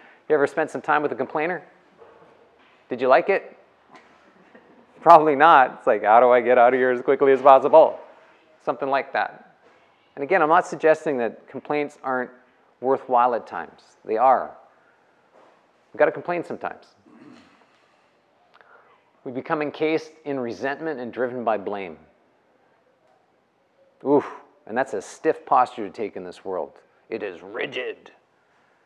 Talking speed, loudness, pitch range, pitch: 150 wpm, -21 LUFS, 125-155 Hz, 135 Hz